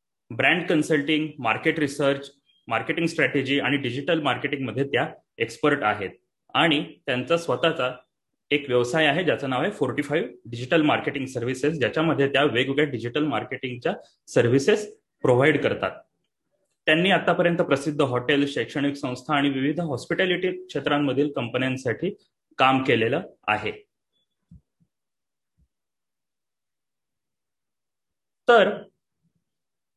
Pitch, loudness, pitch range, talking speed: 145 Hz, -23 LUFS, 130-160 Hz, 100 wpm